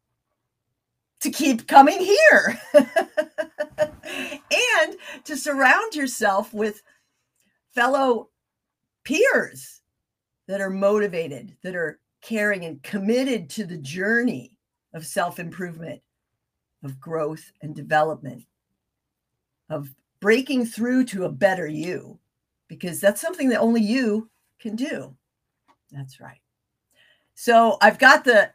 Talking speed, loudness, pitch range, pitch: 105 wpm, -21 LUFS, 160-265 Hz, 210 Hz